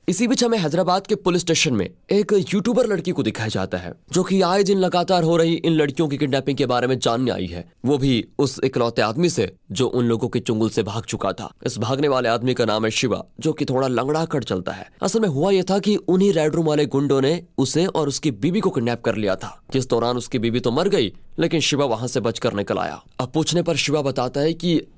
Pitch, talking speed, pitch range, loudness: 140 Hz, 250 wpm, 120-175 Hz, -21 LUFS